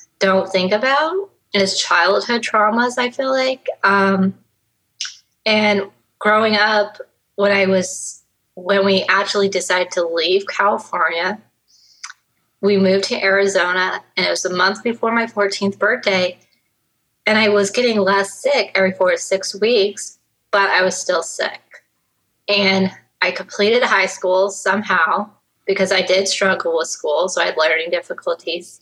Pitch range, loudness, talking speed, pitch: 190-230 Hz, -17 LUFS, 145 wpm, 200 Hz